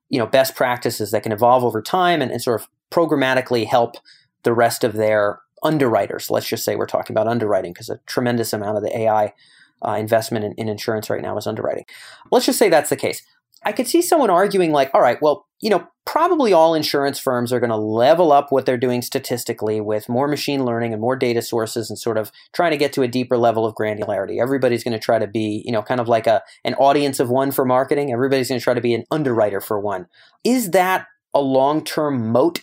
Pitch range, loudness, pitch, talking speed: 115-140 Hz, -19 LUFS, 125 Hz, 235 wpm